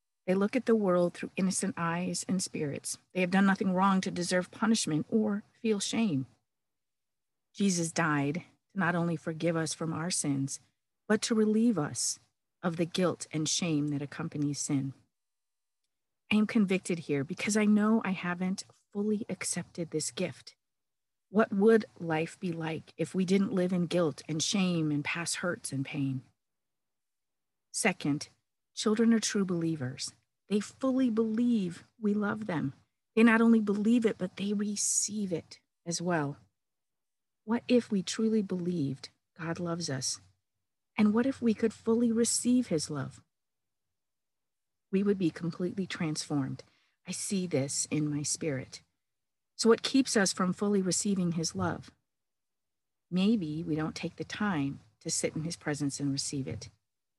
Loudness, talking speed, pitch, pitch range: -30 LUFS, 155 wpm, 175 Hz, 150-210 Hz